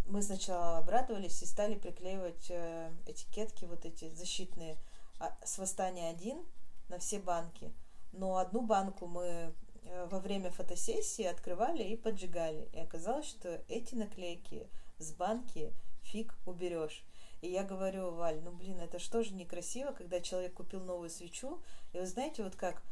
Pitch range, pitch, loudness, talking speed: 170-200 Hz, 180 Hz, -41 LUFS, 145 wpm